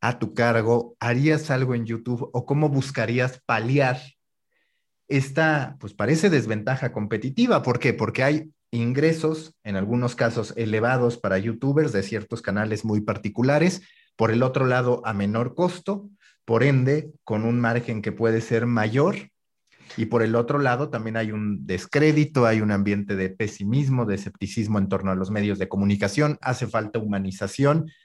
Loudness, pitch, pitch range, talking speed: -23 LUFS, 120 Hz, 110-140 Hz, 160 wpm